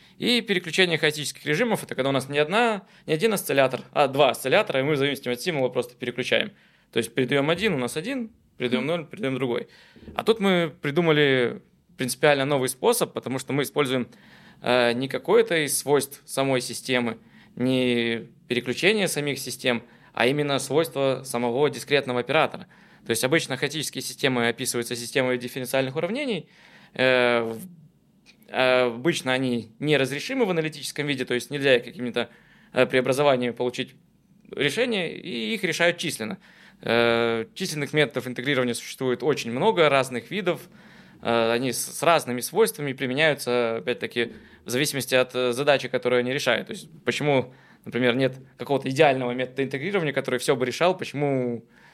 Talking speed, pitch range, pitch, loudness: 145 wpm, 125-155 Hz, 135 Hz, -24 LUFS